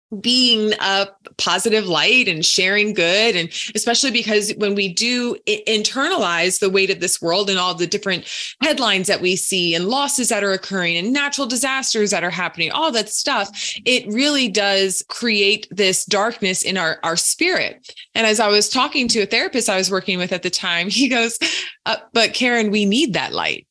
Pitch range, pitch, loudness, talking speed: 190-240 Hz, 210 Hz, -17 LUFS, 190 wpm